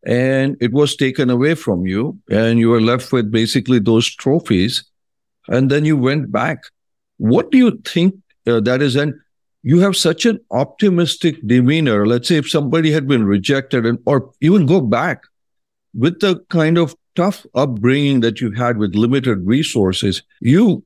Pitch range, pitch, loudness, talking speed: 120-160 Hz, 135 Hz, -16 LUFS, 170 wpm